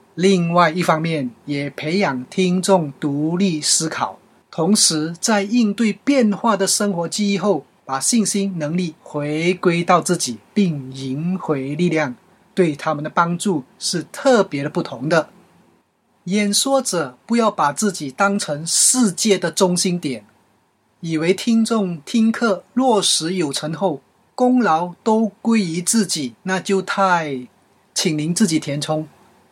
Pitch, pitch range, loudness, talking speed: 180 Hz, 155-205 Hz, -19 LUFS, 200 characters per minute